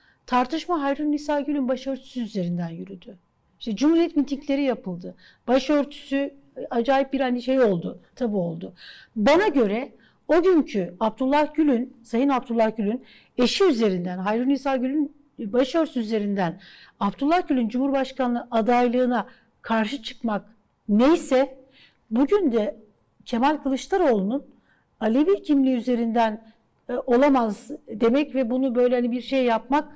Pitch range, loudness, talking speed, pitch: 225-280 Hz, -23 LUFS, 120 wpm, 255 Hz